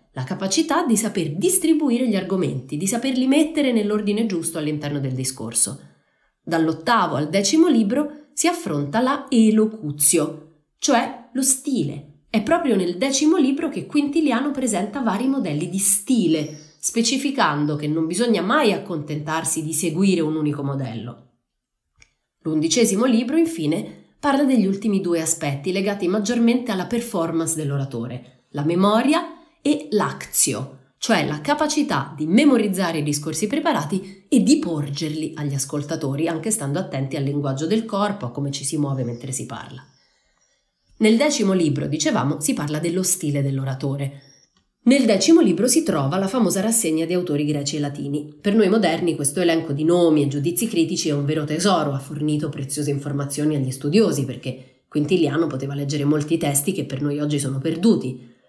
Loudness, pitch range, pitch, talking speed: -20 LUFS, 145-230 Hz, 165 Hz, 150 wpm